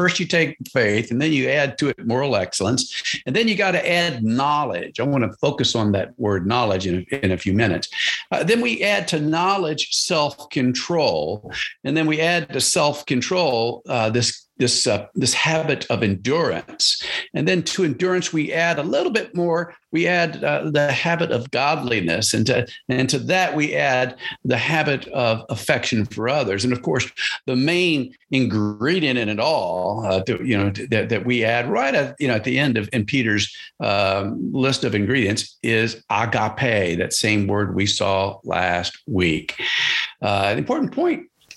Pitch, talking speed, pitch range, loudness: 130 Hz, 190 wpm, 110-155 Hz, -20 LUFS